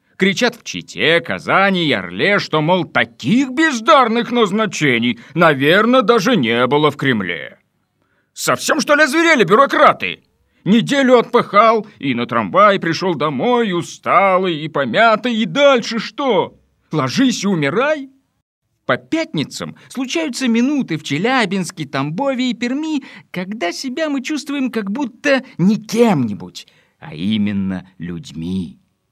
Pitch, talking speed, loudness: 220 Hz, 120 wpm, -15 LUFS